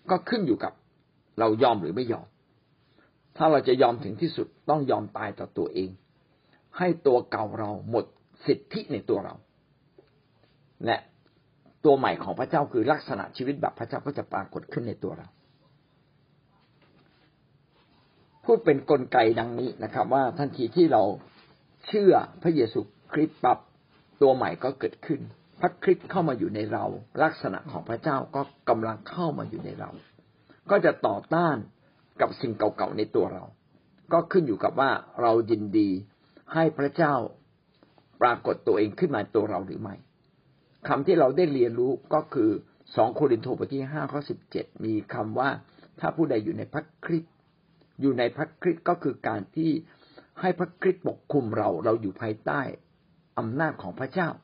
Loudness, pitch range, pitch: -27 LUFS, 120-170 Hz, 150 Hz